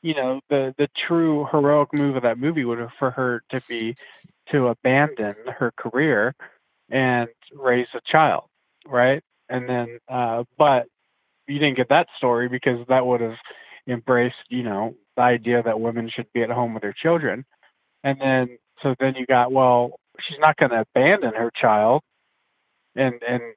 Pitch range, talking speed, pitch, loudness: 120-135 Hz, 175 wpm, 125 Hz, -21 LUFS